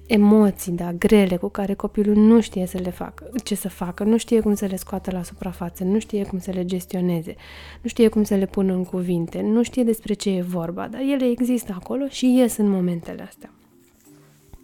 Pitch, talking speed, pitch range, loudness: 200 Hz, 210 wpm, 185-220 Hz, -21 LUFS